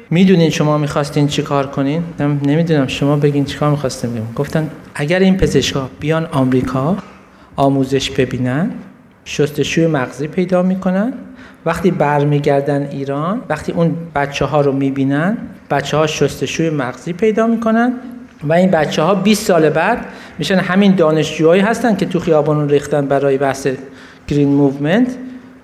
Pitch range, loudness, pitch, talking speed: 140-185 Hz, -15 LUFS, 155 Hz, 140 wpm